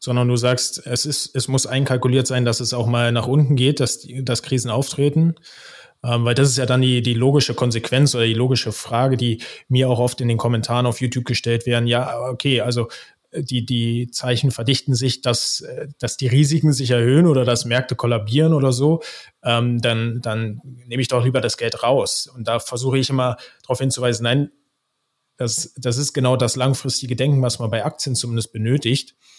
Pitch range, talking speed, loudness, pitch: 120-135 Hz, 200 wpm, -19 LUFS, 125 Hz